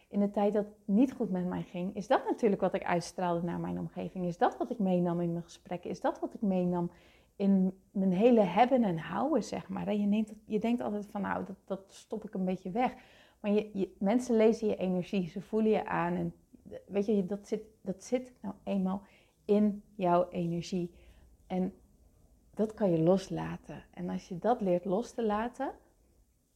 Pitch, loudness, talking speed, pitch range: 195 Hz, -32 LUFS, 205 wpm, 180-215 Hz